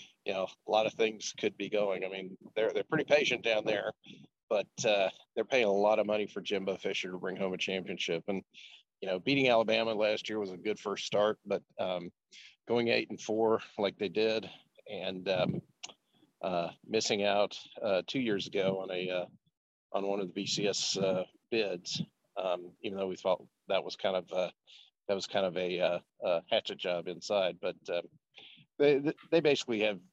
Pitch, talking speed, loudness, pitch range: 100 Hz, 195 wpm, -33 LUFS, 95-110 Hz